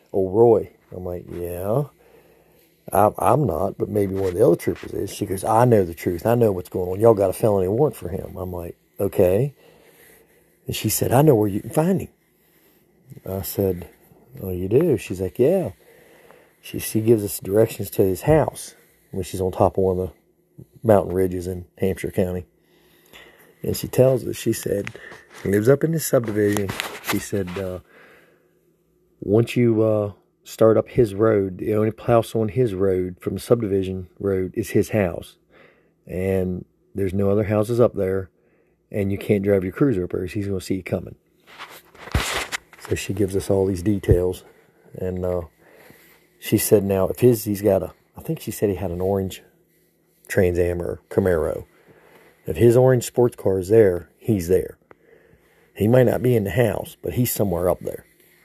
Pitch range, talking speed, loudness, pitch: 95-120 Hz, 185 wpm, -21 LUFS, 100 Hz